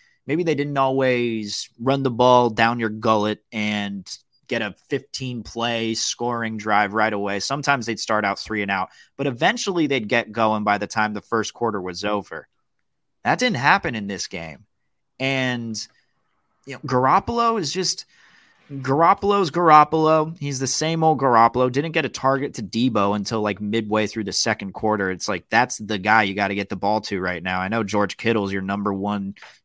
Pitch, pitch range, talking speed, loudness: 115 Hz, 105-135 Hz, 185 wpm, -21 LUFS